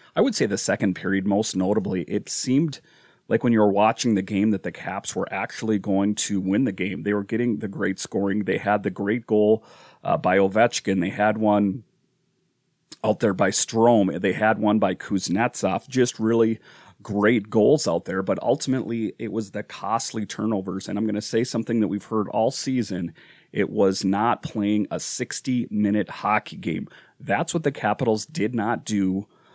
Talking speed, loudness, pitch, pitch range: 190 wpm, -23 LUFS, 105 Hz, 100-115 Hz